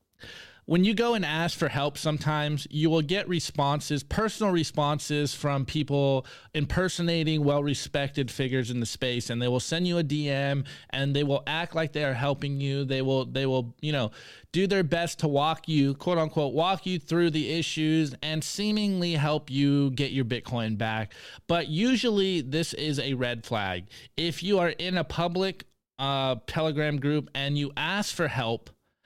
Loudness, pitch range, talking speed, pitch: -27 LUFS, 135-170 Hz, 175 wpm, 150 Hz